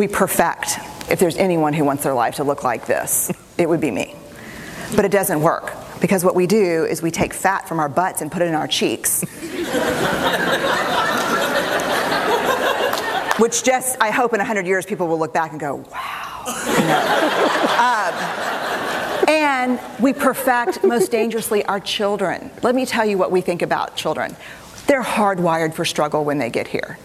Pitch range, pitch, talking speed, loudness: 165-230 Hz, 190 Hz, 175 wpm, -19 LUFS